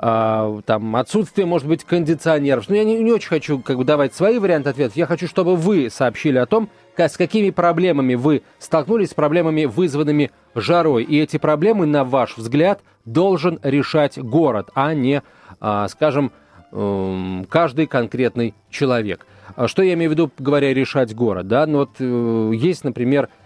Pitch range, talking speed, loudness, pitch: 125-170 Hz, 160 wpm, -18 LUFS, 150 Hz